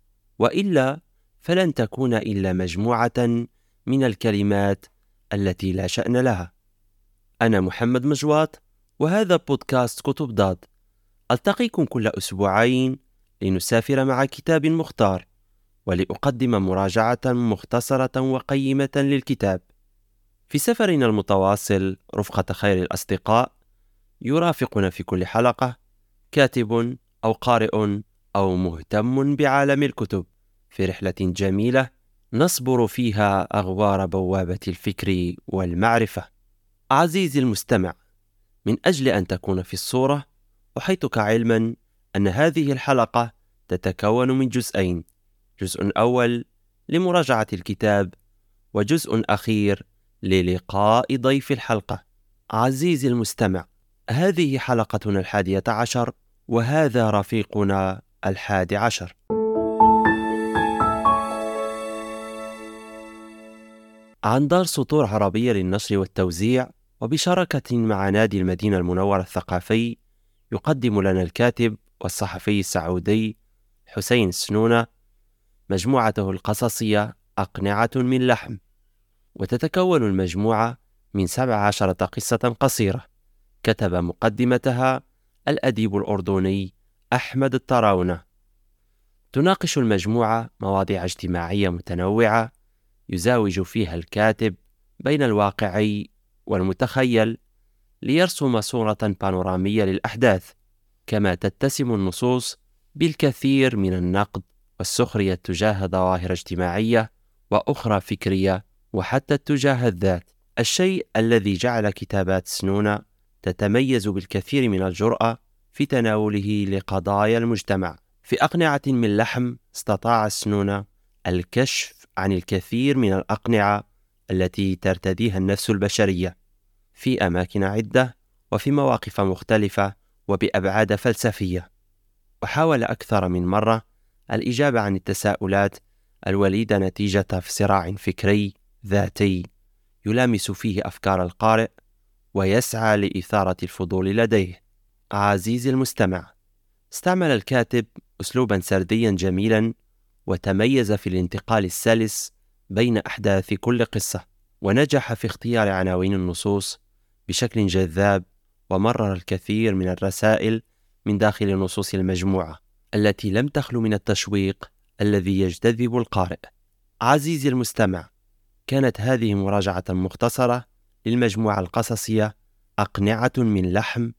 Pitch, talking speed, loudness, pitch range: 105 Hz, 90 wpm, -22 LUFS, 100-120 Hz